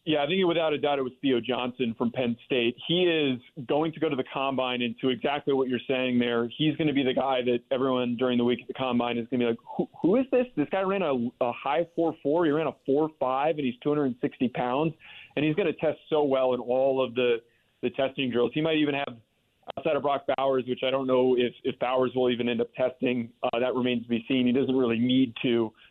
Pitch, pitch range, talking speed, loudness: 130 Hz, 125-145 Hz, 270 wpm, -27 LUFS